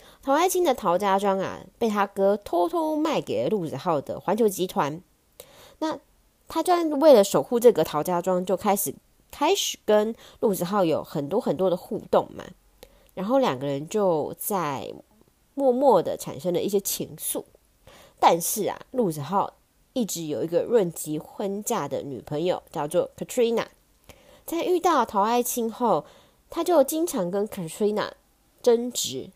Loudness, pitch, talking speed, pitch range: -25 LUFS, 225 Hz, 240 characters per minute, 190-280 Hz